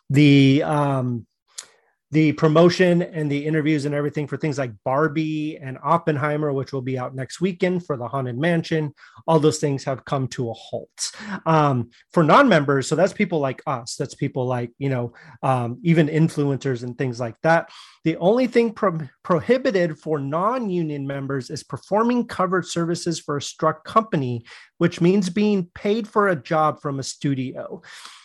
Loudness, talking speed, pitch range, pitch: -21 LUFS, 170 wpm, 135-170 Hz, 155 Hz